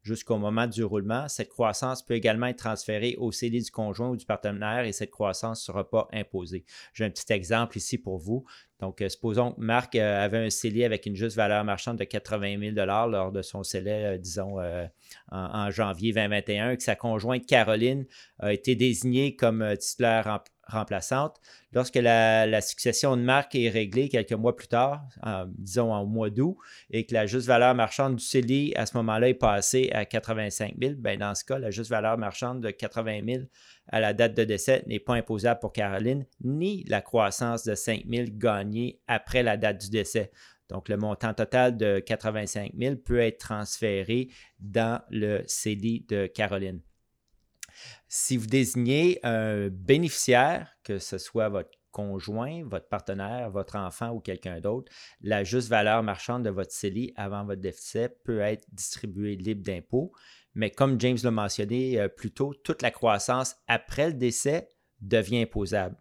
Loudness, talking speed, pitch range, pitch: -28 LUFS, 175 wpm, 105-120 Hz, 110 Hz